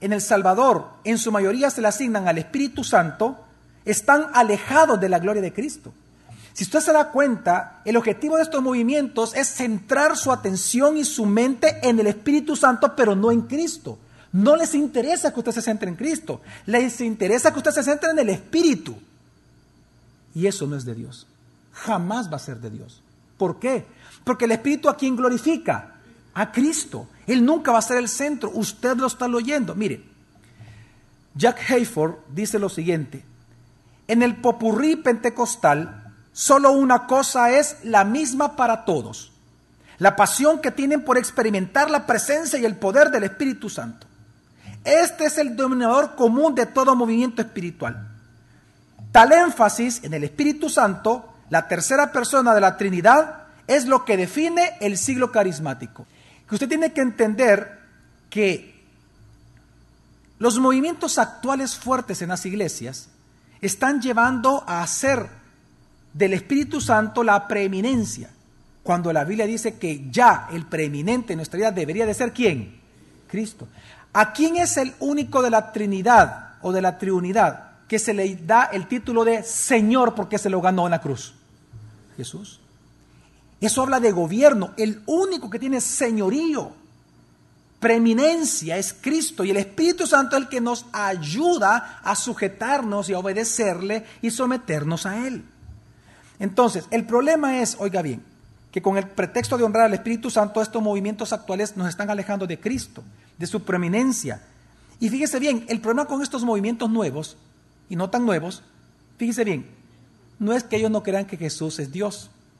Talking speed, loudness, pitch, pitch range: 160 wpm, -21 LUFS, 220 Hz, 185-260 Hz